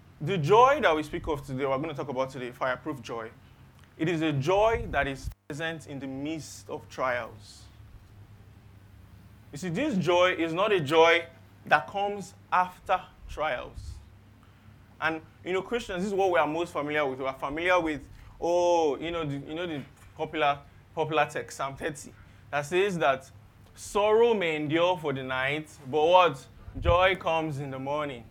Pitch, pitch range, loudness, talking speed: 145 Hz, 110-170 Hz, -27 LUFS, 175 wpm